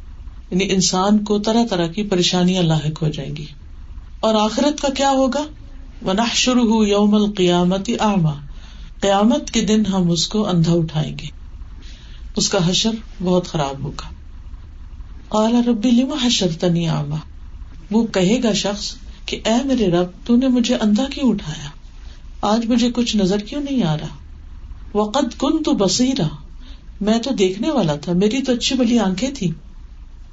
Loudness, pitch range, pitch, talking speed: -18 LUFS, 150-230 Hz, 190 Hz, 145 wpm